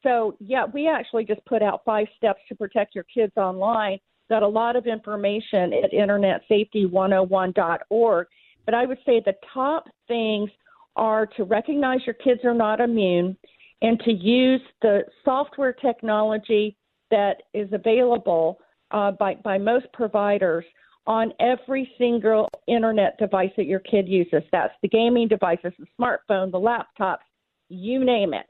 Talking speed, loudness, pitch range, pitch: 145 wpm, -22 LUFS, 200-240 Hz, 220 Hz